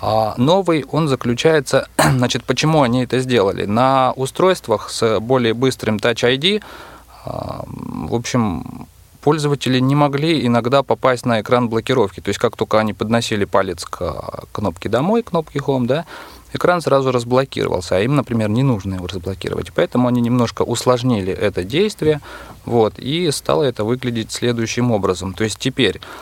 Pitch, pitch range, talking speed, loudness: 125 Hz, 115-135 Hz, 150 wpm, -18 LUFS